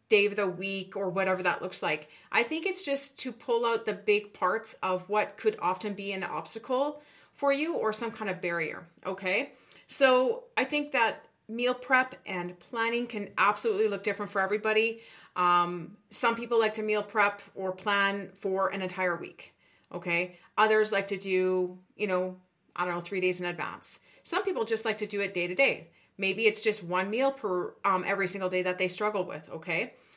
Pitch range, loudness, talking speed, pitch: 185-230 Hz, -29 LUFS, 200 wpm, 205 Hz